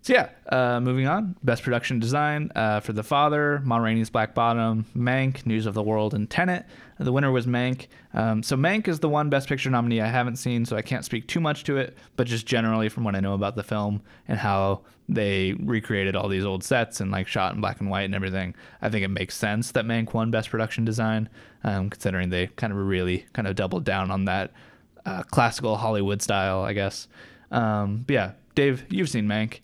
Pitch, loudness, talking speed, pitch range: 110 Hz, -25 LUFS, 225 wpm, 100-125 Hz